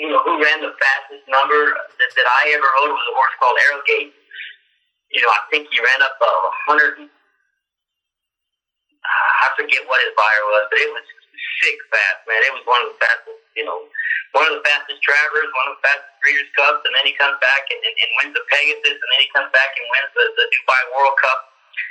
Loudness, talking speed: -16 LUFS, 220 wpm